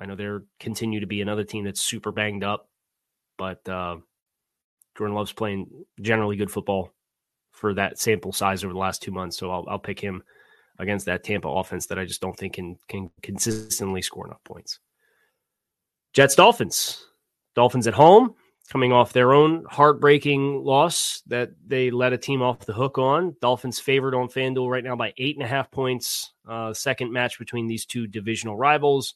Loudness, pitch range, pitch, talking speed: -23 LUFS, 100-130 Hz, 115 Hz, 185 wpm